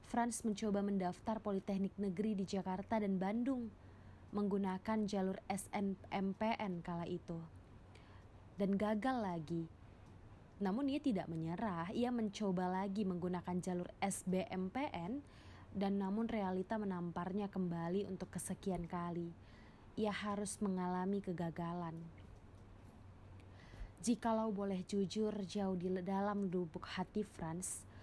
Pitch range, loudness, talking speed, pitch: 170-205 Hz, -41 LUFS, 105 wpm, 190 Hz